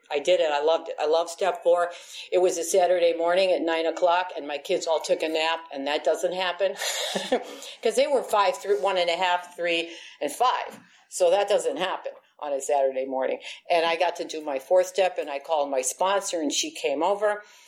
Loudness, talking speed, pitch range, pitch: -25 LUFS, 225 wpm, 160-190 Hz, 175 Hz